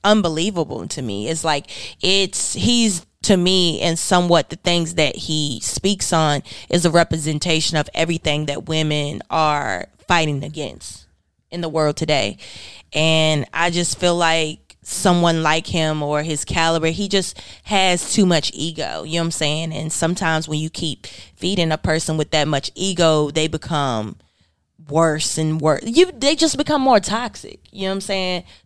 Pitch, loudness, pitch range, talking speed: 160 Hz, -19 LUFS, 150-175 Hz, 170 wpm